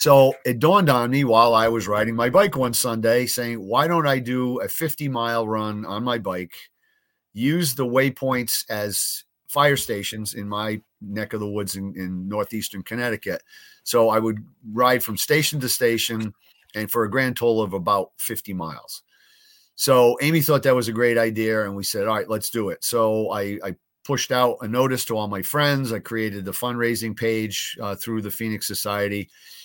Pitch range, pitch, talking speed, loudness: 105-130 Hz, 115 Hz, 190 wpm, -22 LUFS